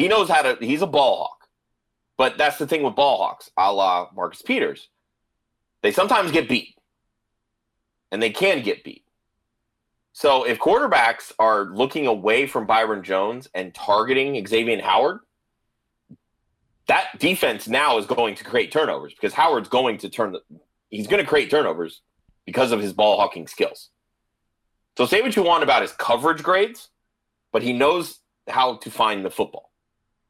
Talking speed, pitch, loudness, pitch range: 165 wpm, 115 Hz, -21 LUFS, 105-120 Hz